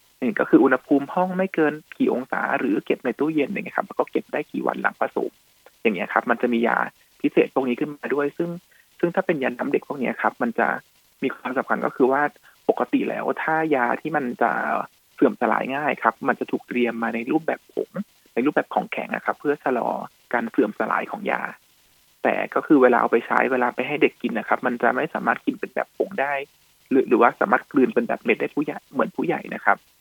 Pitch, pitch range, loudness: 145 Hz, 120-155 Hz, -23 LUFS